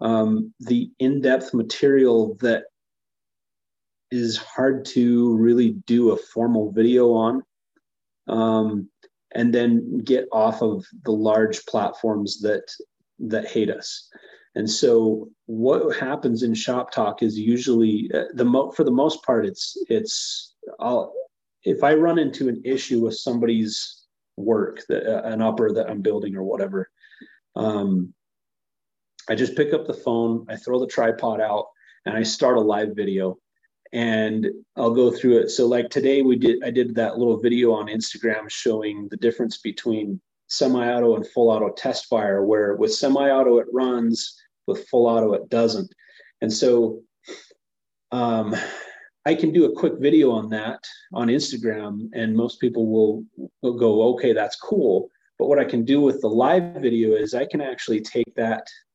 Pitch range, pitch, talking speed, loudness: 110-125 Hz, 115 Hz, 160 wpm, -21 LUFS